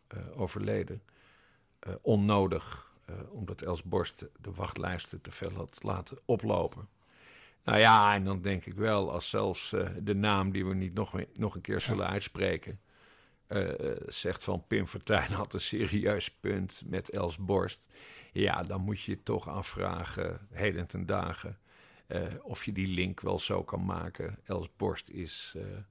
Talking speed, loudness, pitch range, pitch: 165 wpm, -33 LUFS, 95-105 Hz, 100 Hz